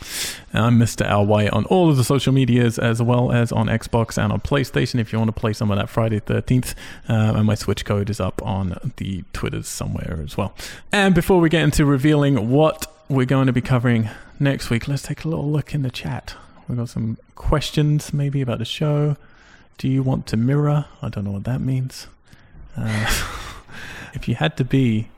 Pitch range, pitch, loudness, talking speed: 110-140 Hz, 120 Hz, -20 LUFS, 210 wpm